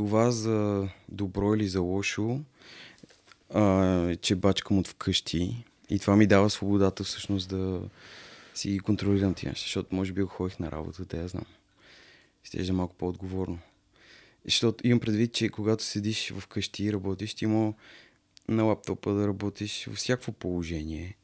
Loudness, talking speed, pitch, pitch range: -28 LUFS, 145 wpm, 100 Hz, 95-105 Hz